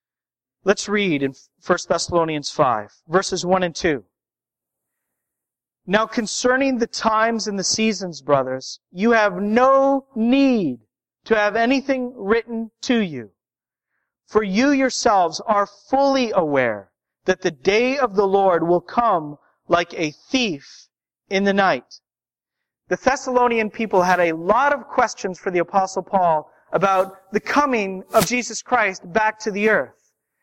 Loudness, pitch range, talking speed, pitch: -20 LUFS, 180-235 Hz, 140 wpm, 205 Hz